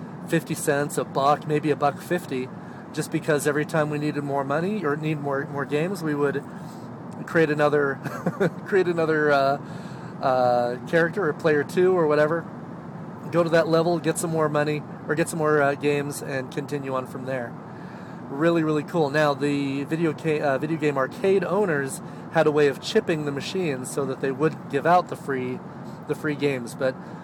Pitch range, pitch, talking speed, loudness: 140-170 Hz, 150 Hz, 185 wpm, -24 LUFS